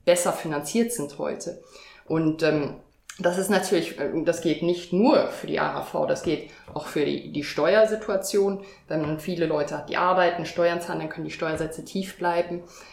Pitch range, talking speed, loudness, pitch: 160-195 Hz, 175 wpm, -25 LUFS, 175 Hz